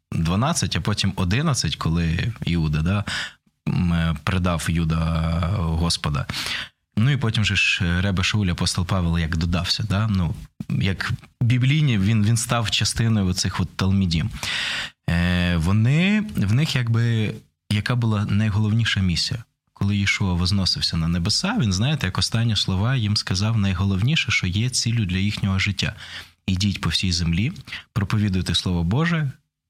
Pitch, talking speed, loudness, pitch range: 100 Hz, 130 wpm, -22 LUFS, 90-115 Hz